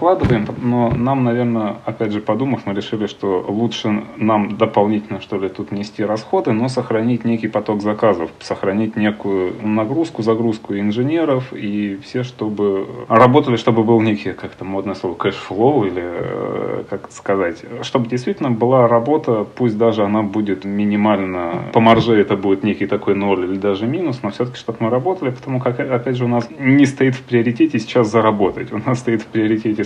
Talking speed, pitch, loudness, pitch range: 165 wpm, 110 Hz, -18 LUFS, 105-120 Hz